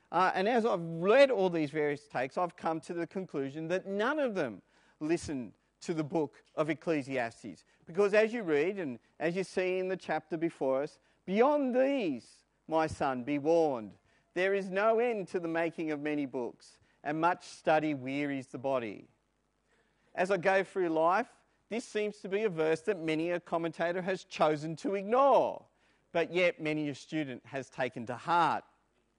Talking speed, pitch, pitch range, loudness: 180 wpm, 165 Hz, 150-195 Hz, -32 LUFS